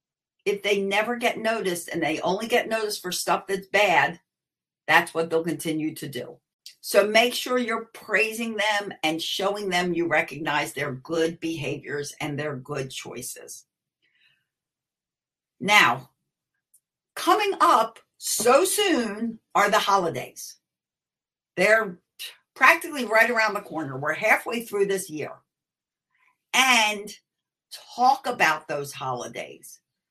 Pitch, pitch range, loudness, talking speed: 195 Hz, 160-225 Hz, -23 LUFS, 125 wpm